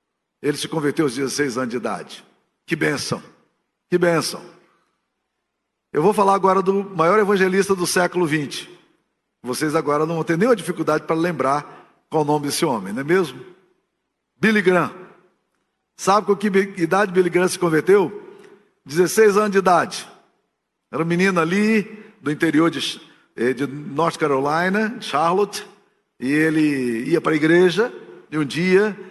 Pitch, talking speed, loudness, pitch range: 175 Hz, 150 wpm, -19 LUFS, 155-195 Hz